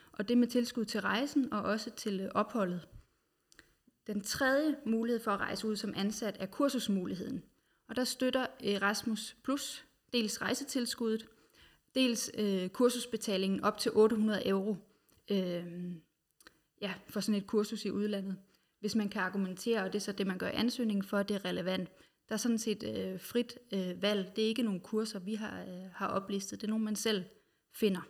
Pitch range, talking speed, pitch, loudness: 195-230 Hz, 185 wpm, 210 Hz, -34 LUFS